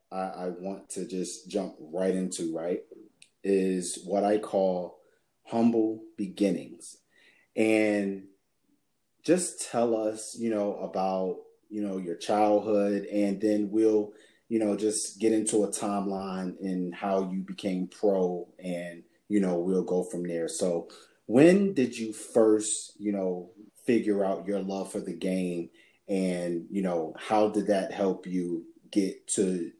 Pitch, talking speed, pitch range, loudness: 100 Hz, 145 wpm, 95-110 Hz, -29 LUFS